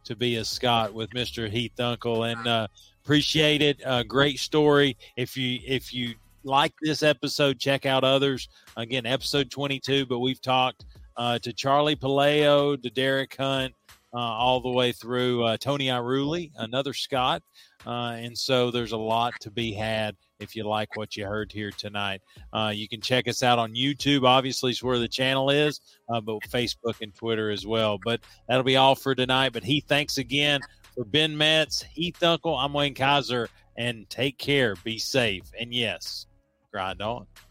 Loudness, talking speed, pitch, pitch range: -25 LUFS, 180 wpm, 125 Hz, 115-135 Hz